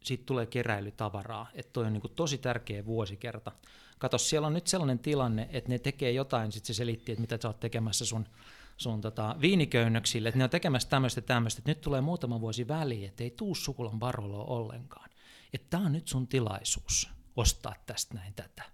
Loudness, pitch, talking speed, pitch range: -32 LUFS, 120 Hz, 190 wpm, 115-135 Hz